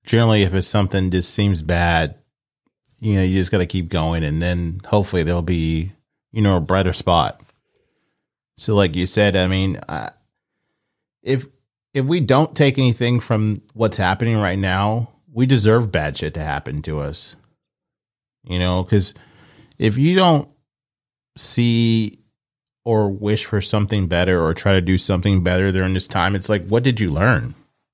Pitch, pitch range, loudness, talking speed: 105 Hz, 95-120 Hz, -19 LUFS, 170 wpm